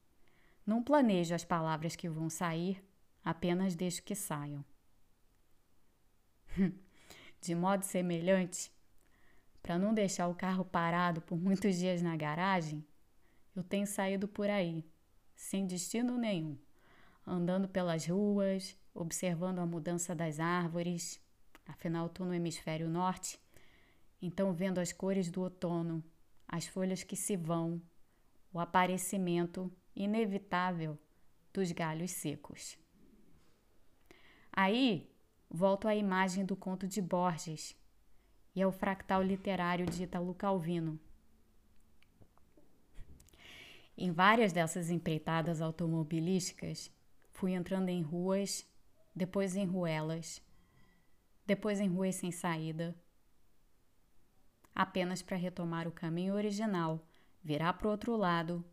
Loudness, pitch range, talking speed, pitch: -36 LUFS, 165-190 Hz, 110 wpm, 175 Hz